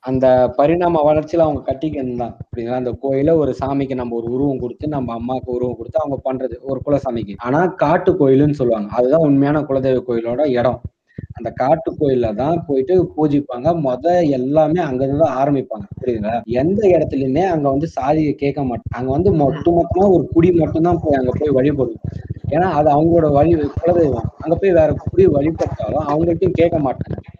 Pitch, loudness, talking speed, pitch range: 140 Hz, -17 LUFS, 165 wpm, 125-160 Hz